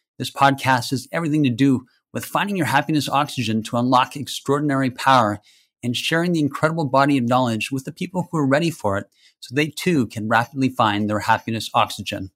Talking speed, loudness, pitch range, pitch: 190 wpm, -20 LUFS, 115-145 Hz, 135 Hz